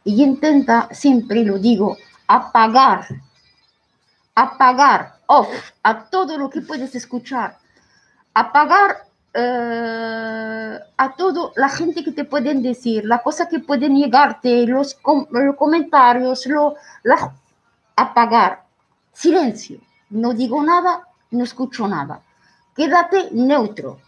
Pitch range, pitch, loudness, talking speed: 235-295 Hz, 265 Hz, -17 LUFS, 110 wpm